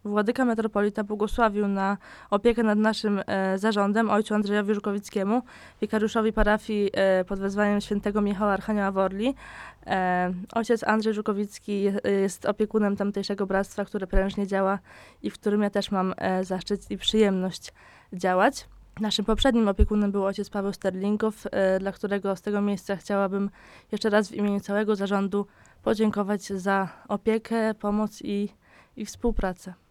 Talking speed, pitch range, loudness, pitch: 140 wpm, 195-215 Hz, -26 LUFS, 205 Hz